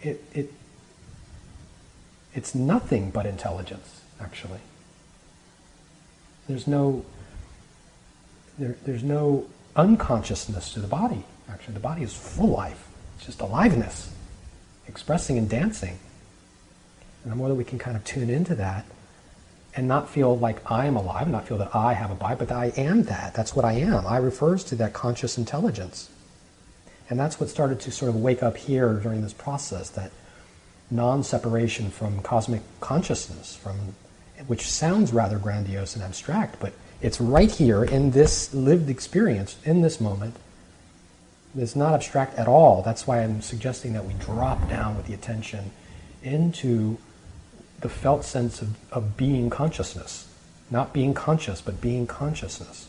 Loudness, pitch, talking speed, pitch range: -25 LUFS, 115 Hz, 150 wpm, 95-135 Hz